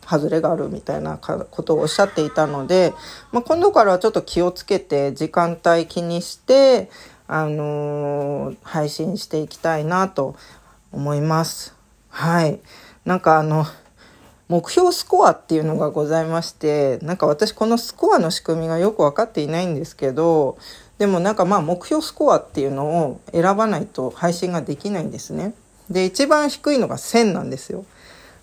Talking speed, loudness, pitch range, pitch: 300 characters per minute, -20 LUFS, 155-200 Hz, 170 Hz